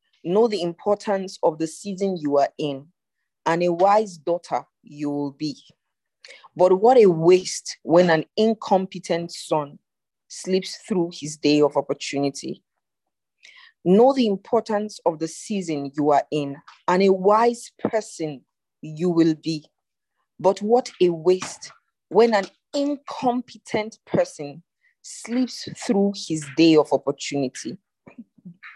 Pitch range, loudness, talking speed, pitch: 155-210 Hz, -22 LUFS, 125 wpm, 180 Hz